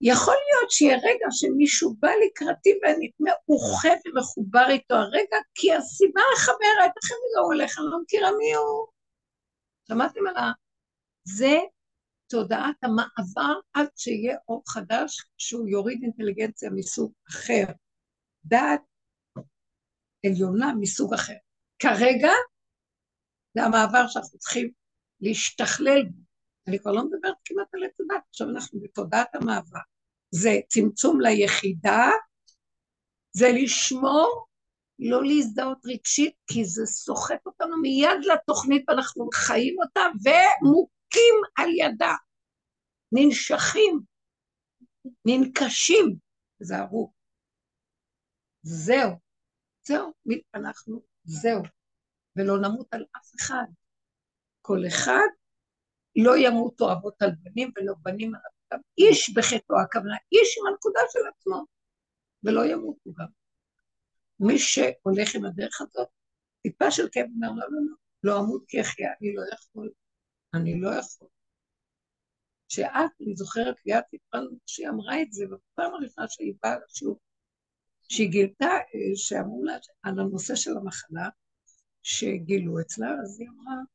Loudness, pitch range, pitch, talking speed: -24 LUFS, 215-325 Hz, 250 Hz, 120 wpm